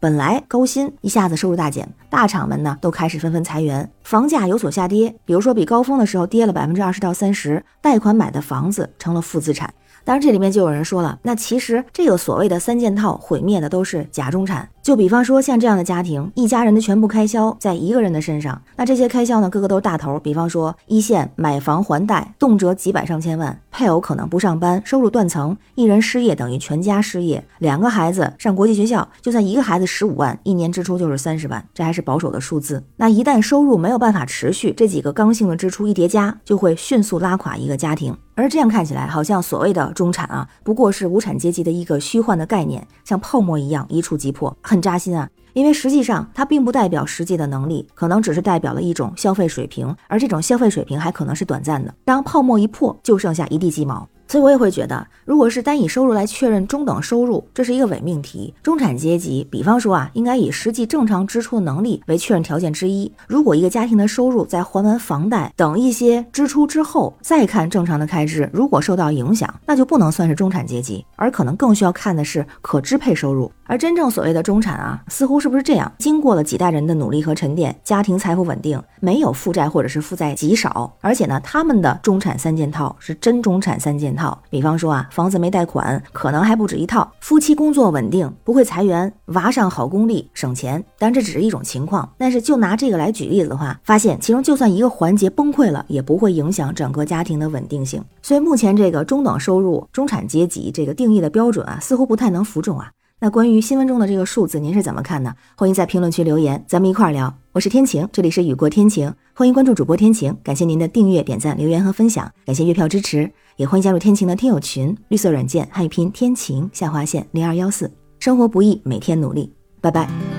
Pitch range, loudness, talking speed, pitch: 160-230 Hz, -17 LUFS, 355 characters per minute, 185 Hz